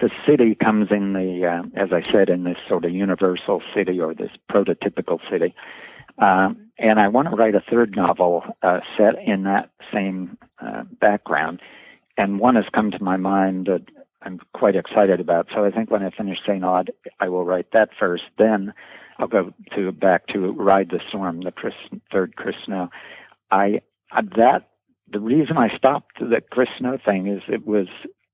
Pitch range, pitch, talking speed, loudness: 90-105 Hz, 100 Hz, 185 wpm, -20 LUFS